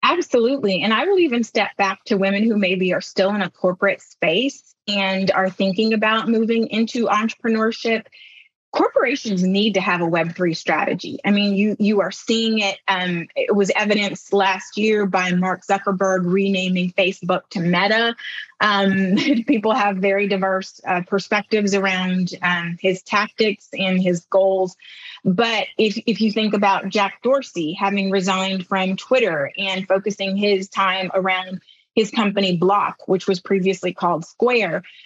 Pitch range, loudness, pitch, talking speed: 190-220 Hz, -19 LUFS, 195 Hz, 155 wpm